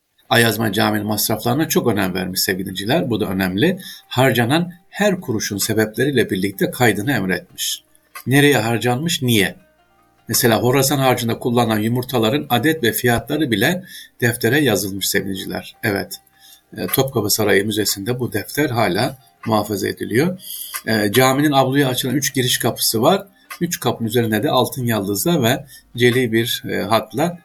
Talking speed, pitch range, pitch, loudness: 125 wpm, 110-135 Hz, 120 Hz, -18 LUFS